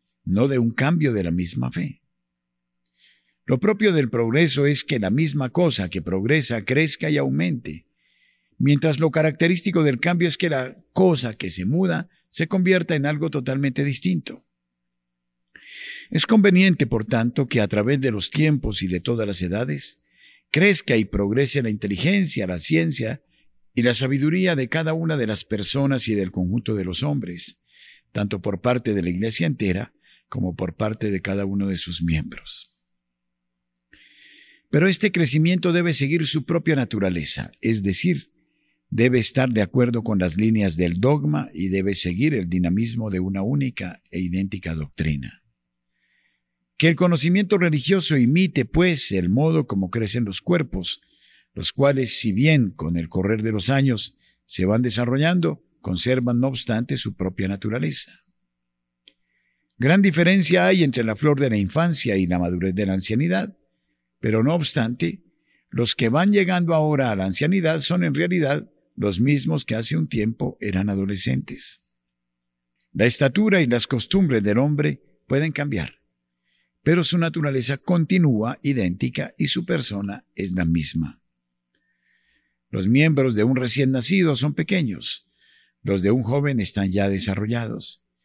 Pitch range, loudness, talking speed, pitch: 90-155 Hz, -21 LUFS, 155 wpm, 115 Hz